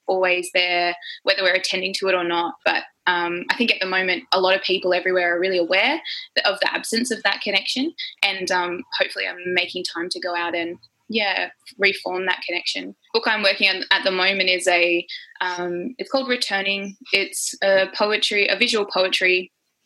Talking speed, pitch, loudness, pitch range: 195 wpm, 185 Hz, -20 LUFS, 180-200 Hz